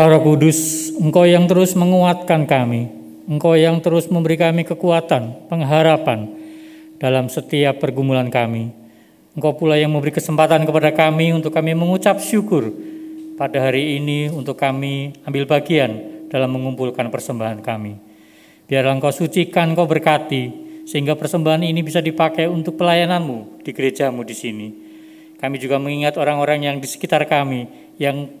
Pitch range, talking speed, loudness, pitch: 135-170 Hz, 135 wpm, -17 LUFS, 155 Hz